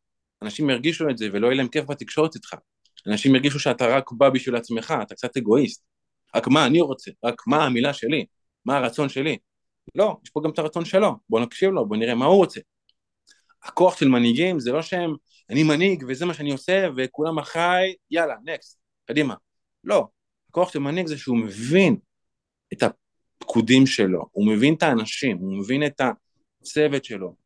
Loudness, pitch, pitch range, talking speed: -22 LUFS, 145 Hz, 120-170 Hz, 180 wpm